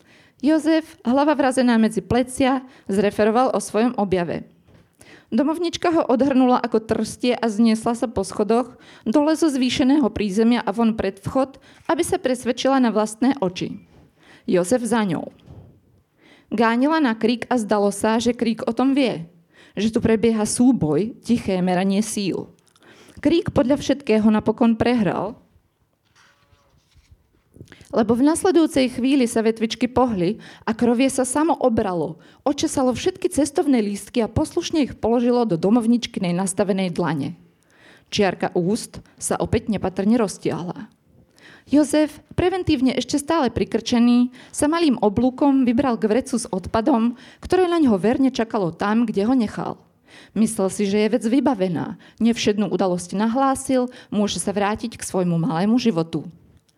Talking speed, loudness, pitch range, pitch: 135 wpm, -20 LUFS, 210-265 Hz, 235 Hz